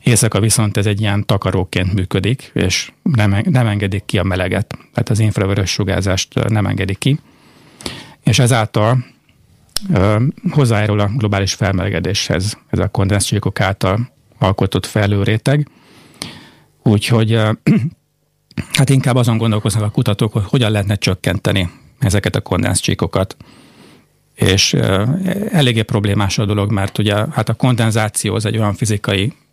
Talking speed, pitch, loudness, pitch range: 130 wpm, 110 Hz, -16 LUFS, 100-125 Hz